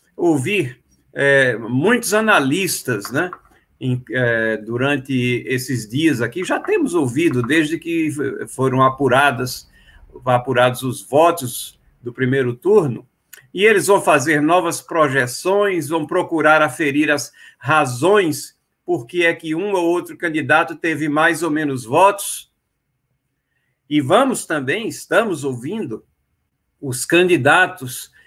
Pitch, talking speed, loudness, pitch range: 150 Hz, 115 wpm, -17 LUFS, 130-175 Hz